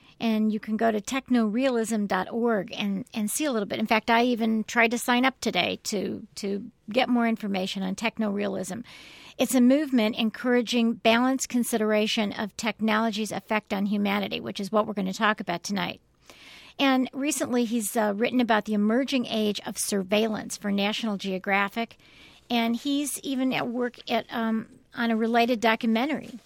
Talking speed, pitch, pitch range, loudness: 165 wpm, 225 Hz, 210-240 Hz, -26 LUFS